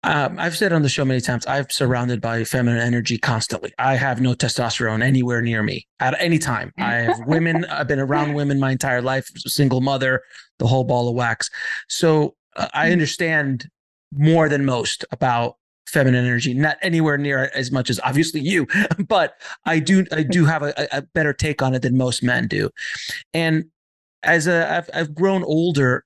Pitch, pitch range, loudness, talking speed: 140 Hz, 125-160 Hz, -20 LUFS, 190 wpm